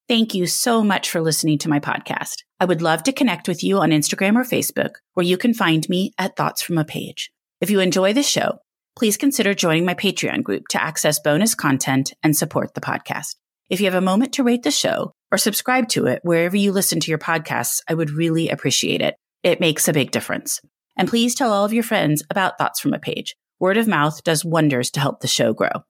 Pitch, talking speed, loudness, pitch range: 180 Hz, 230 wpm, -19 LUFS, 160-210 Hz